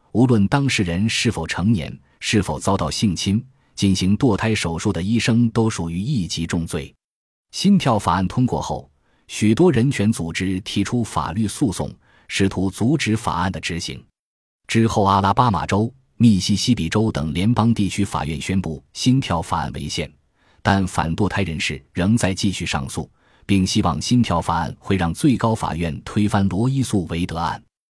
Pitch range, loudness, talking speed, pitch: 85-115 Hz, -20 LUFS, 255 characters per minute, 100 Hz